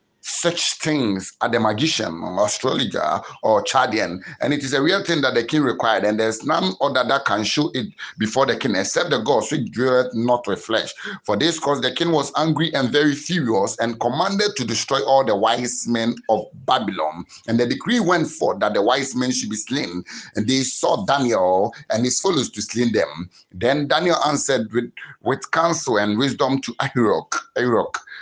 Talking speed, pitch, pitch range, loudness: 190 wpm, 125 Hz, 115-155 Hz, -20 LUFS